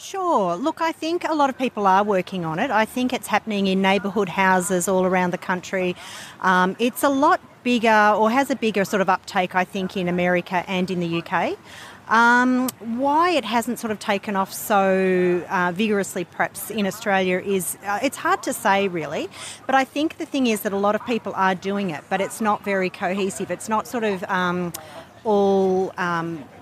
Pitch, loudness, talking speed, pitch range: 195 Hz, -21 LUFS, 205 wpm, 185-235 Hz